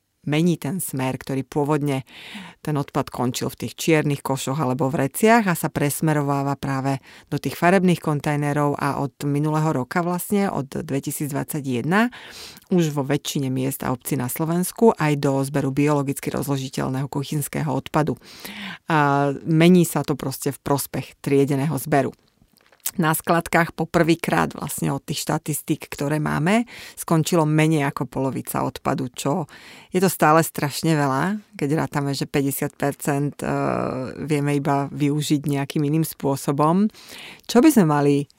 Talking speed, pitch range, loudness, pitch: 140 wpm, 140-160 Hz, -22 LUFS, 145 Hz